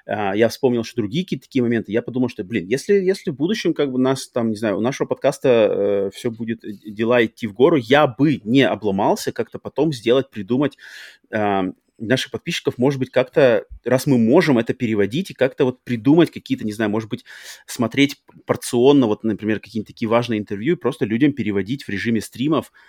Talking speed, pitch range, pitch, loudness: 195 wpm, 110-135 Hz, 120 Hz, -20 LUFS